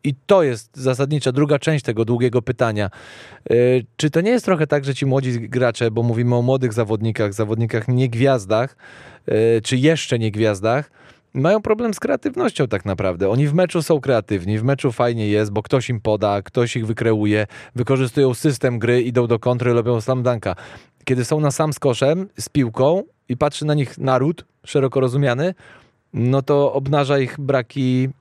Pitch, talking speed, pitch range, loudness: 130 Hz, 170 wpm, 115-140 Hz, -19 LUFS